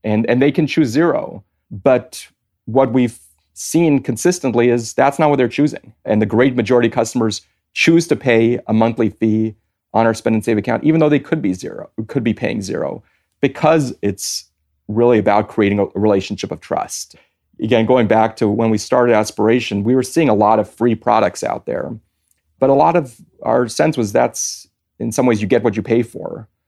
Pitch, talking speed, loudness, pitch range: 115 Hz, 200 wpm, -16 LUFS, 105-130 Hz